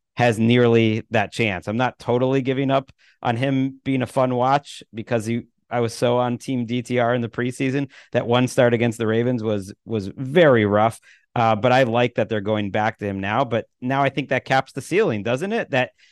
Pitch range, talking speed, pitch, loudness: 115-130 Hz, 215 wpm, 120 Hz, -21 LUFS